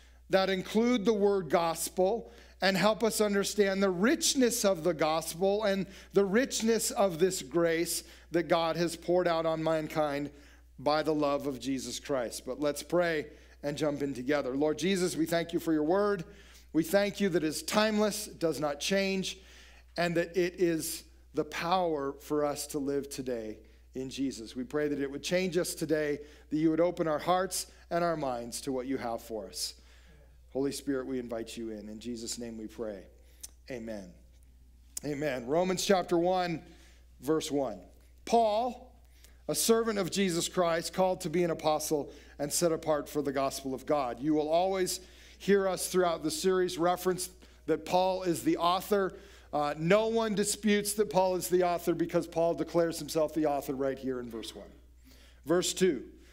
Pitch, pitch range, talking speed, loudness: 160 Hz, 135-185 Hz, 180 wpm, -31 LUFS